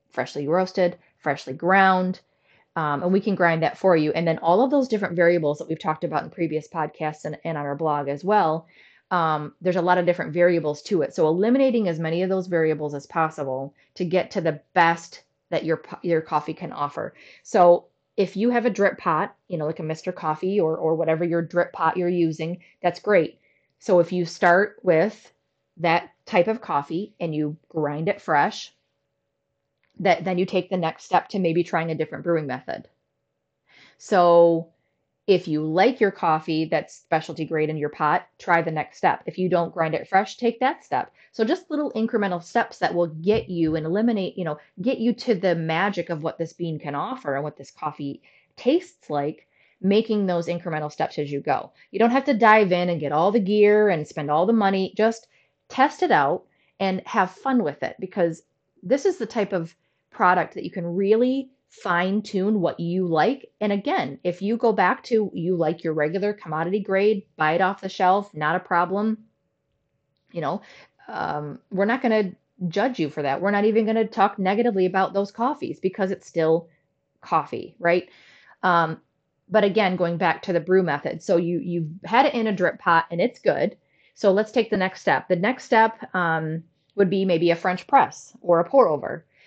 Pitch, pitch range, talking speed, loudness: 175 Hz, 160-205 Hz, 205 wpm, -23 LUFS